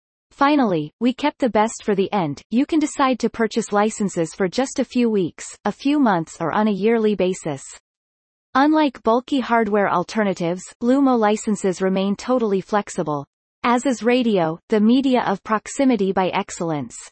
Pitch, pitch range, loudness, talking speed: 215 Hz, 190-250 Hz, -20 LUFS, 160 wpm